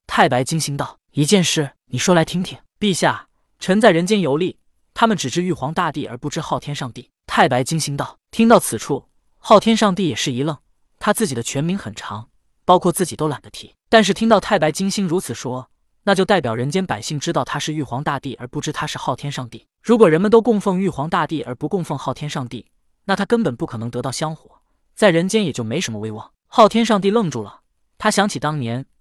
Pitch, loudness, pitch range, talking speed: 155 Hz, -19 LUFS, 130-195 Hz, 325 characters per minute